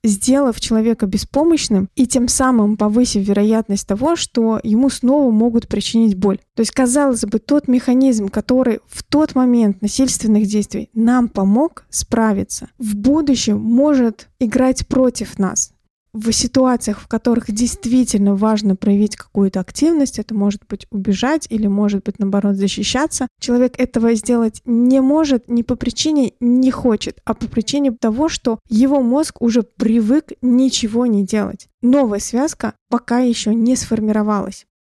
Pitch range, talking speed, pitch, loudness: 215-255 Hz, 140 wpm, 235 Hz, -16 LUFS